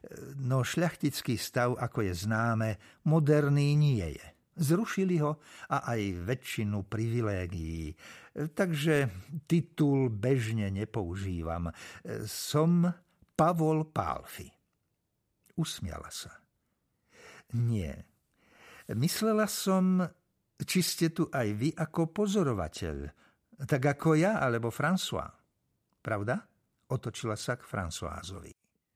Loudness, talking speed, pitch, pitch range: -31 LUFS, 90 wpm, 135 Hz, 110-165 Hz